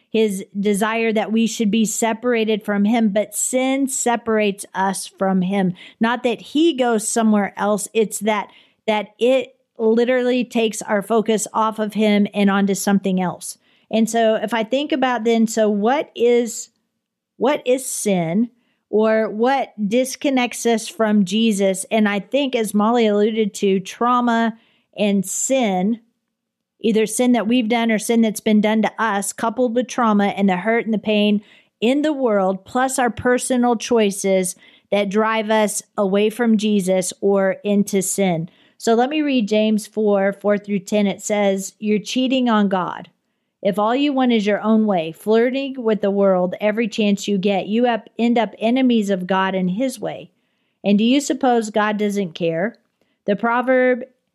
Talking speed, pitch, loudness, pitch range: 170 wpm, 220 Hz, -19 LUFS, 205-240 Hz